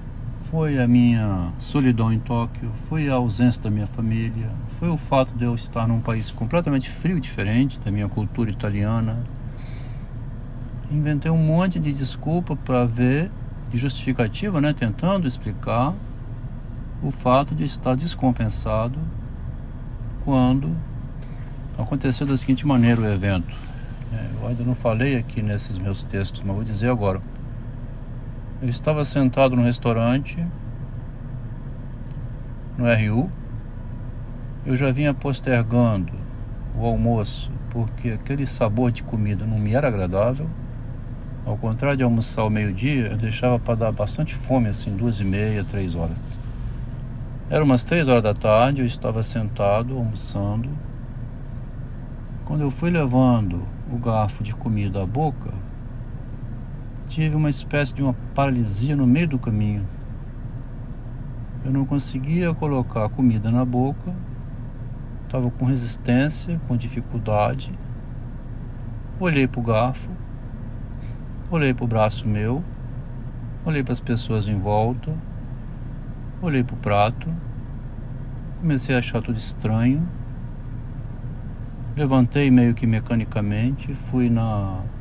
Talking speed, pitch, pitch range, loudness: 125 wpm, 120 Hz, 115-130 Hz, -22 LUFS